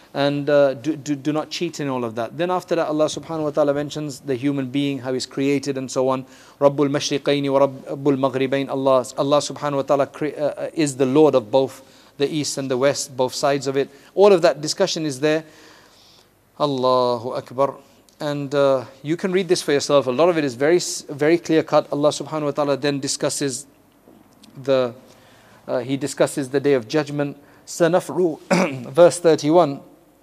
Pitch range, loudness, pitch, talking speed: 135-155 Hz, -20 LUFS, 145 Hz, 180 wpm